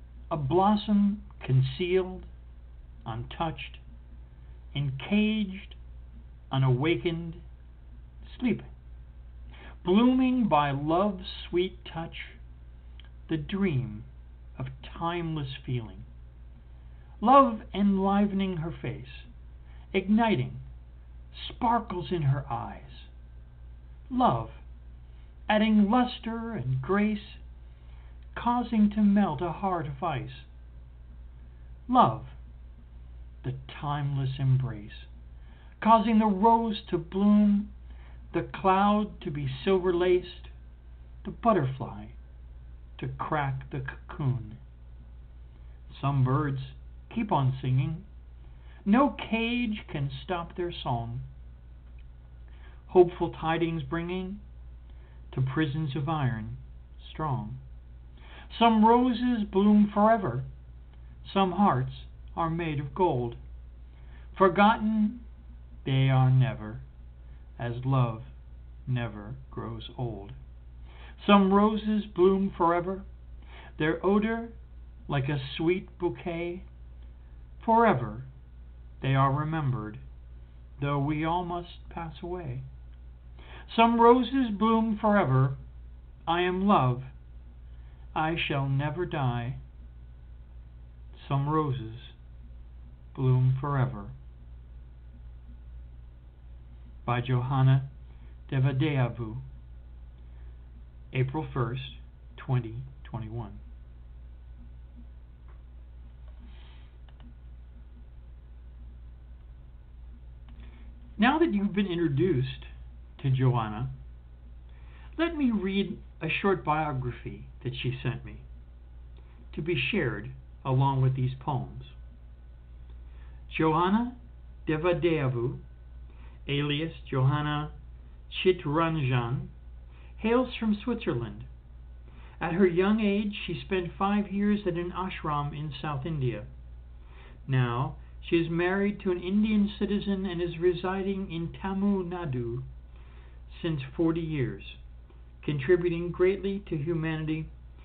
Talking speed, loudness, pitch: 85 wpm, -28 LUFS, 120 Hz